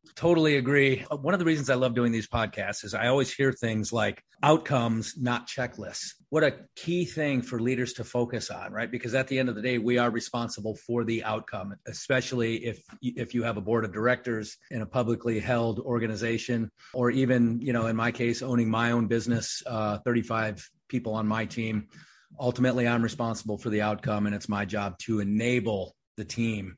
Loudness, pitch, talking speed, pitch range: -28 LUFS, 120 Hz, 195 wpm, 110-125 Hz